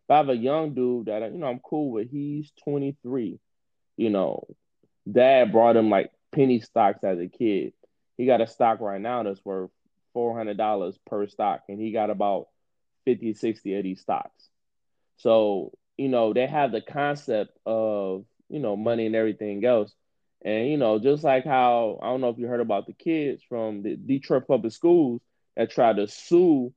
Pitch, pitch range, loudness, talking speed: 115 Hz, 105-130 Hz, -25 LUFS, 185 wpm